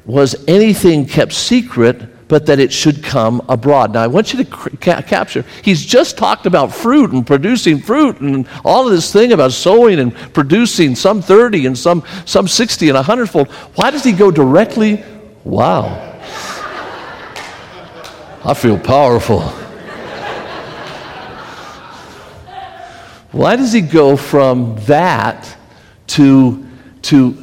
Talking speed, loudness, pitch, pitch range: 130 wpm, -11 LUFS, 160 Hz, 135-215 Hz